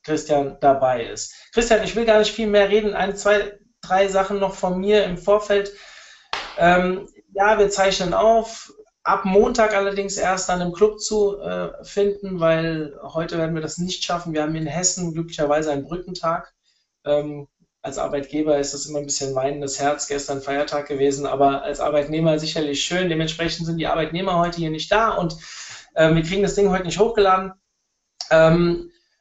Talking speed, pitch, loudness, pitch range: 175 wpm, 175 Hz, -20 LUFS, 155-200 Hz